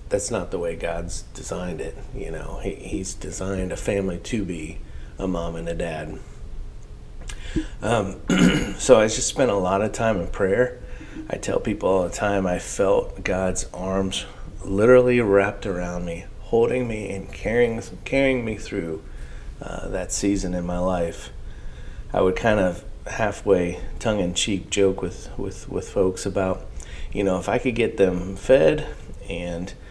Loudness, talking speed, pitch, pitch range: -23 LUFS, 165 wpm, 95 Hz, 85-105 Hz